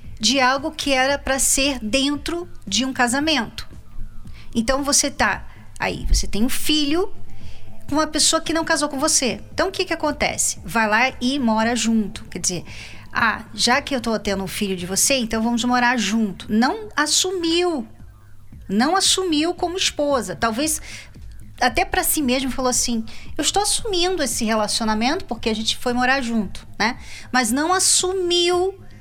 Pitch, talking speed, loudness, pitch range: 255 Hz, 165 wpm, -20 LUFS, 220-310 Hz